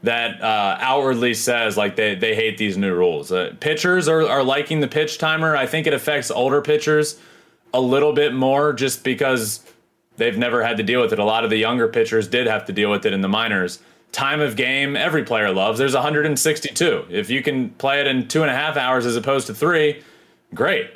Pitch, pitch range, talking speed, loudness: 140 Hz, 125-155 Hz, 220 wpm, -19 LUFS